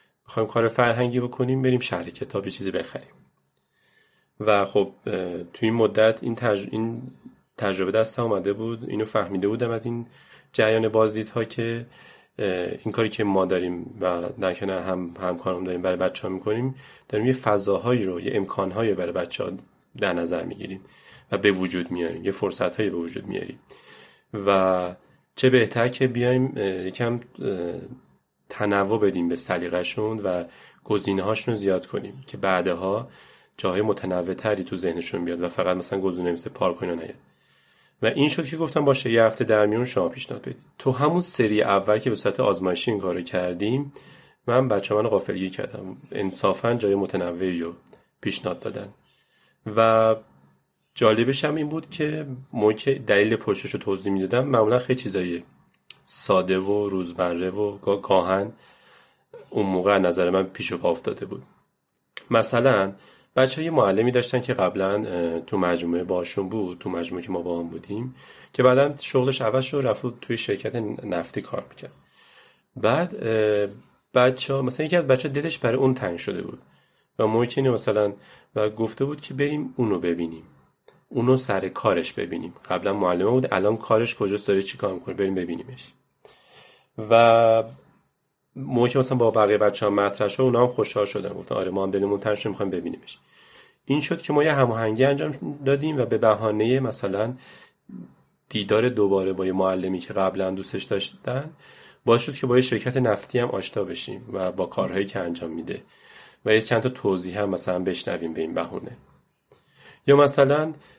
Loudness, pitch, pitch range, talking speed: -24 LUFS, 110 Hz, 95-125 Hz, 160 wpm